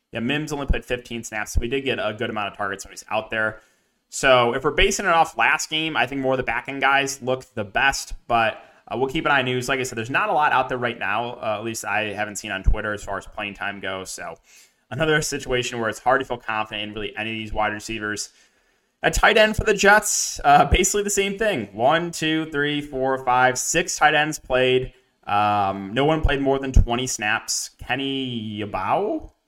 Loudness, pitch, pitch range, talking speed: -22 LUFS, 125 Hz, 105-145 Hz, 240 wpm